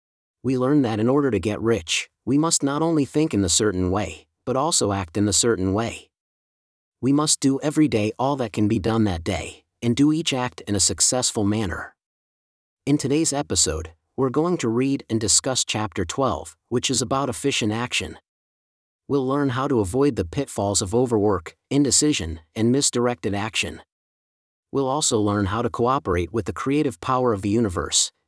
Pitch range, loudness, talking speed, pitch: 100-135 Hz, -22 LUFS, 180 wpm, 115 Hz